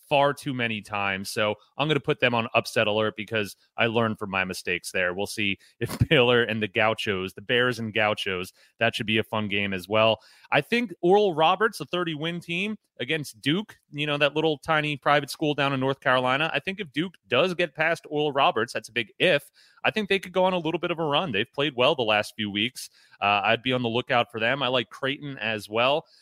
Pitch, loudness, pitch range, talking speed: 130 Hz, -25 LUFS, 110-155 Hz, 240 wpm